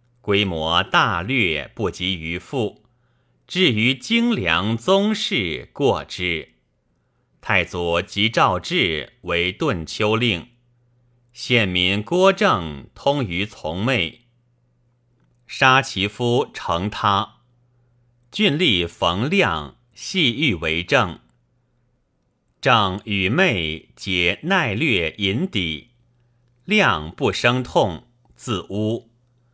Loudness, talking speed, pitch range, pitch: -20 LUFS, 120 characters per minute, 90-120 Hz, 110 Hz